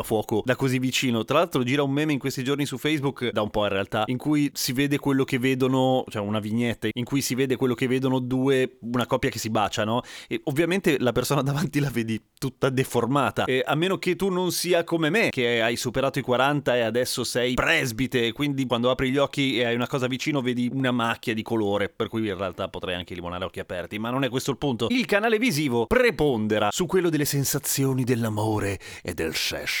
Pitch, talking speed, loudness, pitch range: 130 Hz, 225 wpm, -24 LUFS, 115-140 Hz